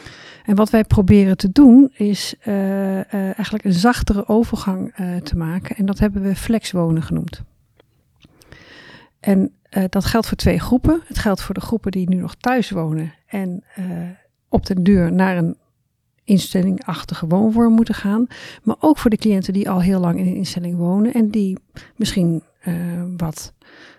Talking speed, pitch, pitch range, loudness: 175 wpm, 195 Hz, 180-215 Hz, -18 LUFS